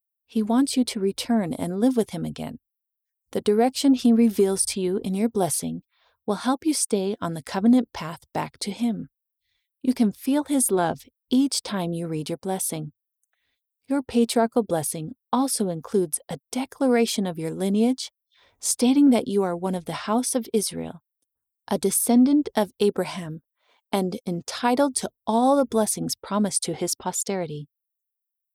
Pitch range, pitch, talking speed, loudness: 180-240 Hz, 205 Hz, 160 wpm, -24 LUFS